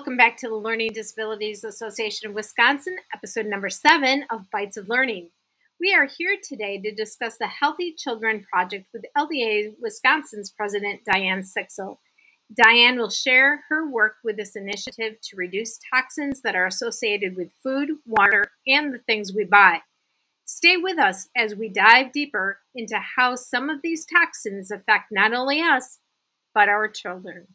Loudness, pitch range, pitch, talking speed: -21 LUFS, 210-275 Hz, 225 Hz, 160 wpm